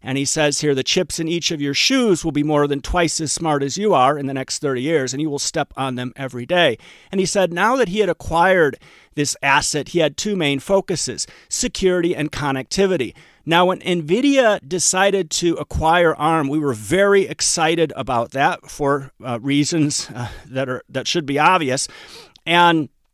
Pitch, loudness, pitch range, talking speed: 155 Hz, -18 LUFS, 140-180 Hz, 195 wpm